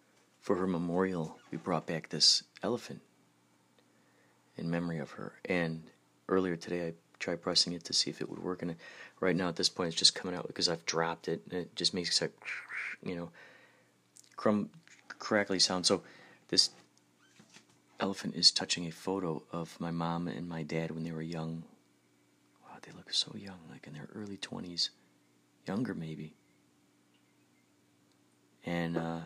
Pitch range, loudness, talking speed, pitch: 60-85 Hz, -33 LUFS, 165 wpm, 80 Hz